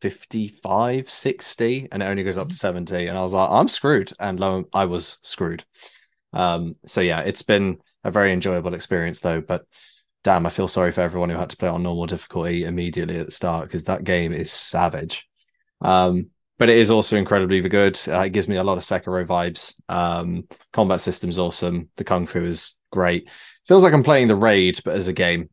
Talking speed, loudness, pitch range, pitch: 210 wpm, -21 LUFS, 85-95 Hz, 90 Hz